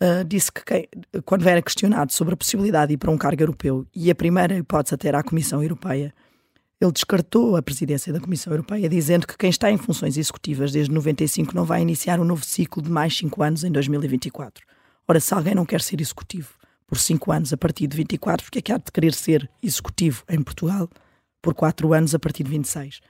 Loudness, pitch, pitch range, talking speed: -22 LUFS, 160 Hz, 150-175 Hz, 220 wpm